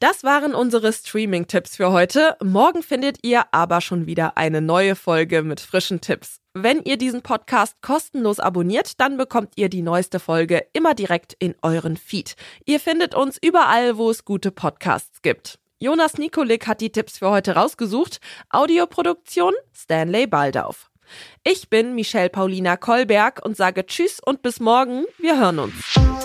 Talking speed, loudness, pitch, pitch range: 155 wpm, -20 LUFS, 225 Hz, 180-275 Hz